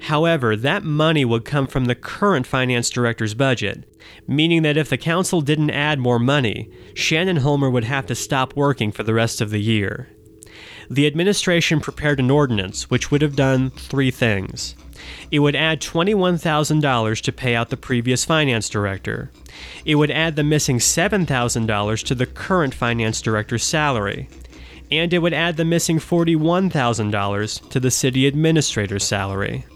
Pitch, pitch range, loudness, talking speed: 135 Hz, 110-155 Hz, -19 LUFS, 155 wpm